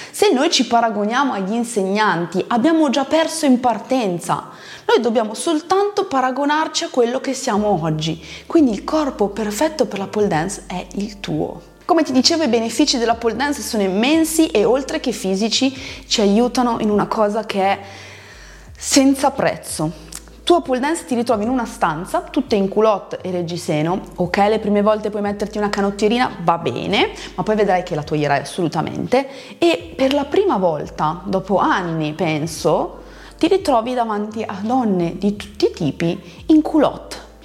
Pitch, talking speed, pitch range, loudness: 220 Hz, 165 wpm, 190-275 Hz, -18 LUFS